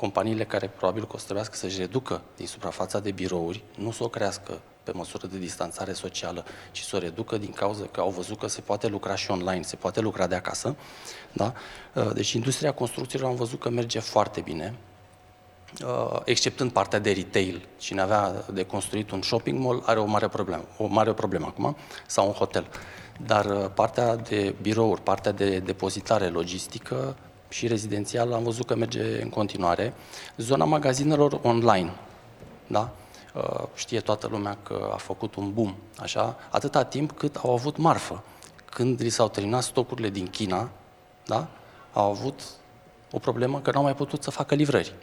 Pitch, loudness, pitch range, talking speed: 105 Hz, -27 LUFS, 95-120 Hz, 170 wpm